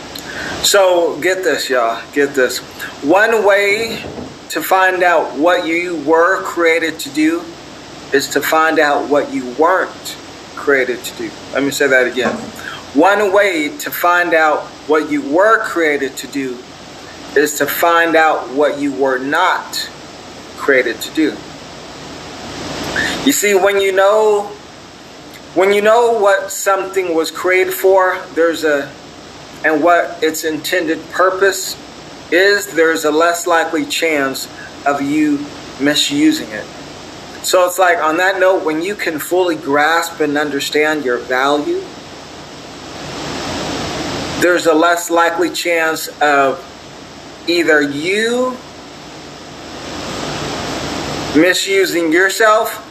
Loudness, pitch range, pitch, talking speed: -14 LUFS, 150-195 Hz, 170 Hz, 125 wpm